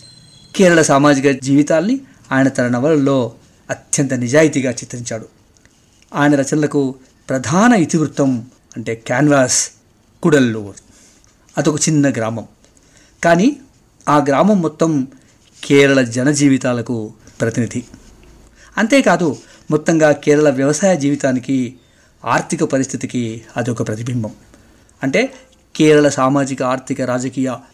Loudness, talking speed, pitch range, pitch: -15 LUFS, 90 wpm, 120-150 Hz, 135 Hz